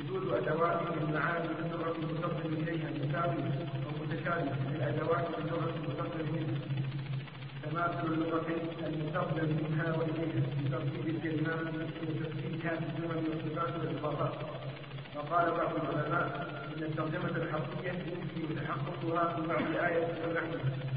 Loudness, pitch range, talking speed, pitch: -35 LUFS, 150-165 Hz, 115 wpm, 160 Hz